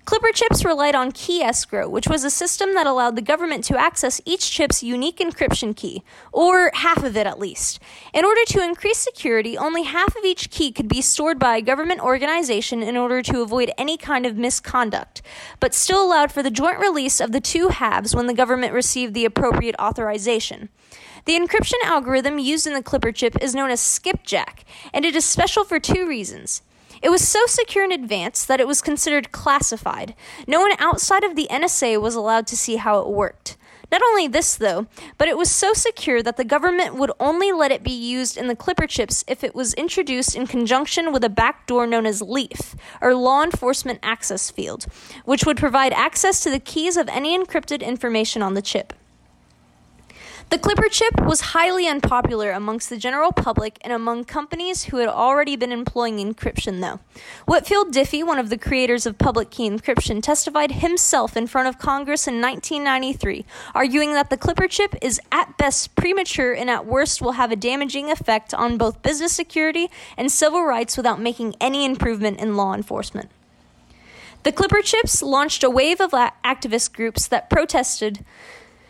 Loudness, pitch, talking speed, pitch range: -20 LUFS, 270 Hz, 185 wpm, 235-330 Hz